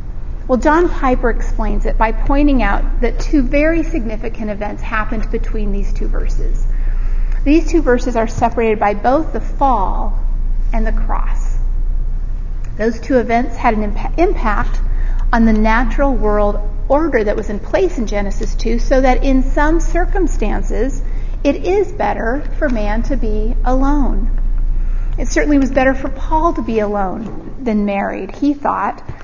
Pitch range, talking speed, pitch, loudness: 220-285 Hz, 150 wpm, 245 Hz, -17 LUFS